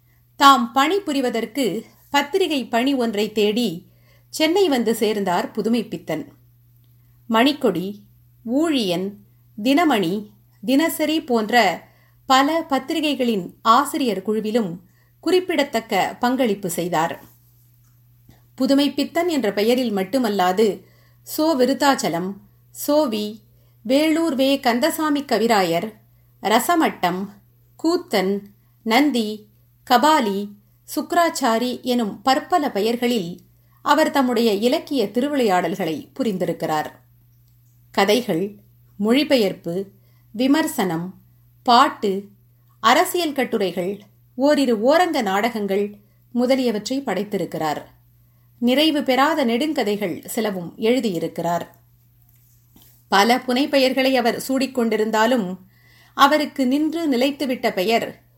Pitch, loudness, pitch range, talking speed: 220 Hz, -20 LUFS, 165-270 Hz, 70 wpm